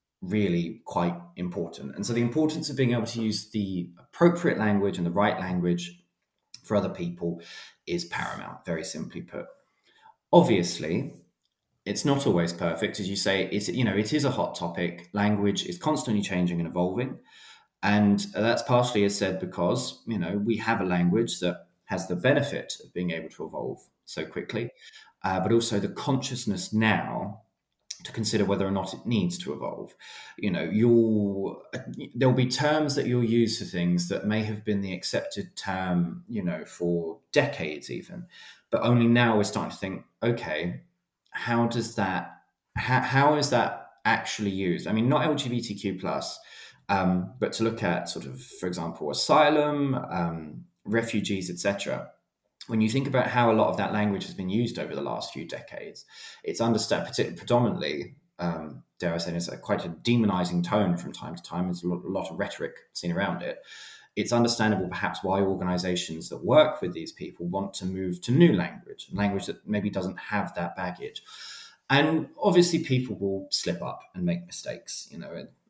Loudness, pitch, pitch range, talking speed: -27 LUFS, 105 Hz, 90-120 Hz, 180 wpm